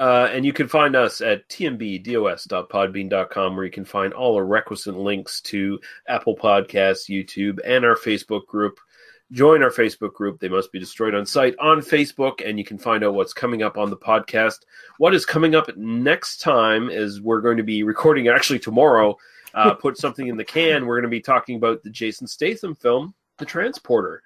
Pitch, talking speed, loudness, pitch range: 110 Hz, 195 wpm, -20 LUFS, 100-130 Hz